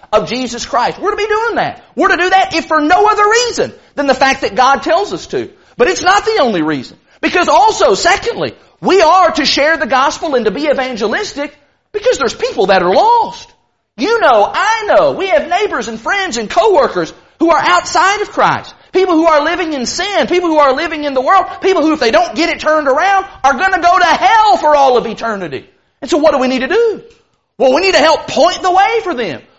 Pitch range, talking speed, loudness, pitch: 285-390 Hz, 235 wpm, -12 LUFS, 350 Hz